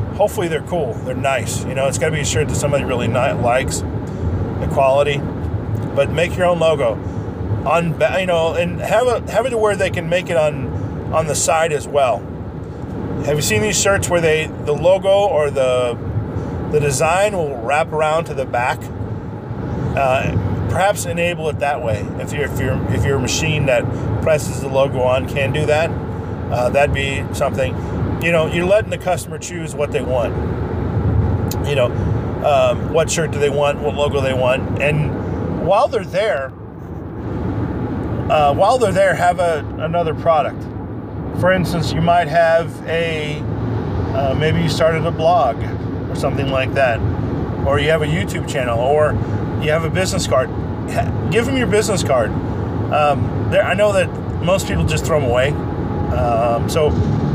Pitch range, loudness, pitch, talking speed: 110-155 Hz, -18 LUFS, 135 Hz, 175 wpm